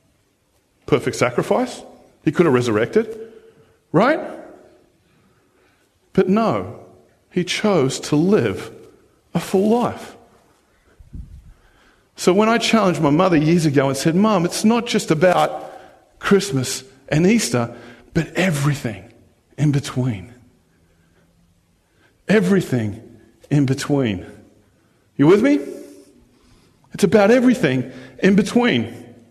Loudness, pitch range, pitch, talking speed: -18 LUFS, 120-200 Hz, 150 Hz, 100 wpm